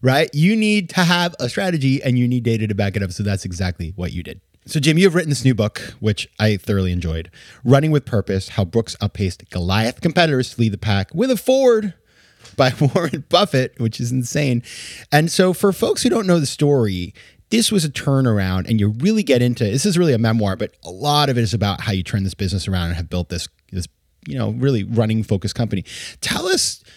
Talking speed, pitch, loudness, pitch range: 230 wpm, 115 Hz, -19 LUFS, 100-145 Hz